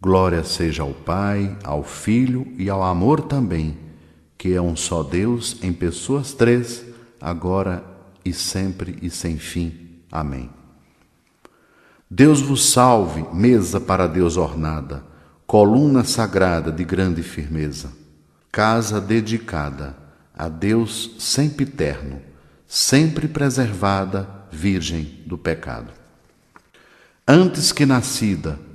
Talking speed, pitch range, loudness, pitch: 105 wpm, 80-115 Hz, -19 LUFS, 95 Hz